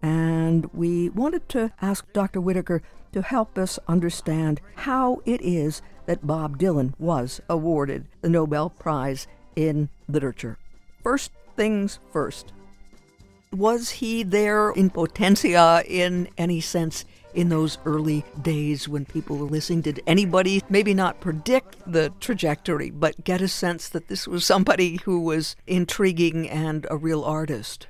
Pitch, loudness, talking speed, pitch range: 165 Hz, -24 LUFS, 140 wpm, 150-185 Hz